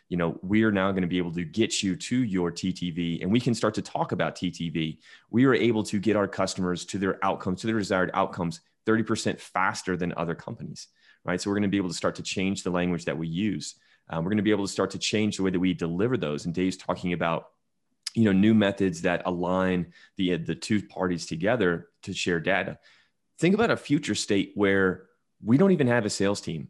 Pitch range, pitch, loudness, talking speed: 90-105 Hz, 95 Hz, -26 LUFS, 235 wpm